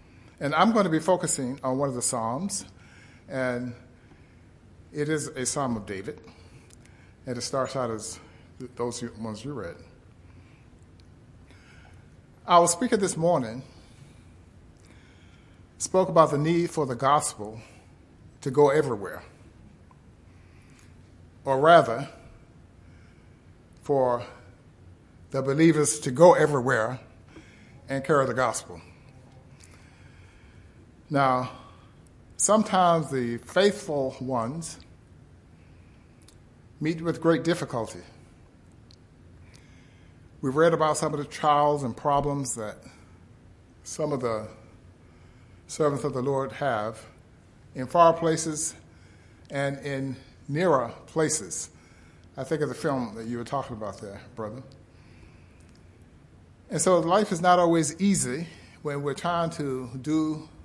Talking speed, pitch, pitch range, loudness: 110 wpm, 130 Hz, 110-150 Hz, -25 LUFS